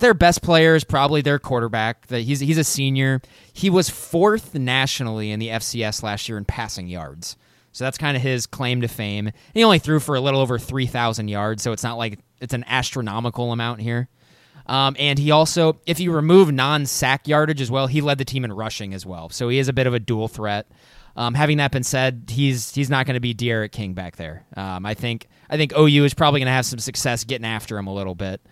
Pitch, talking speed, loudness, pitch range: 130 Hz, 235 wpm, -20 LUFS, 110-145 Hz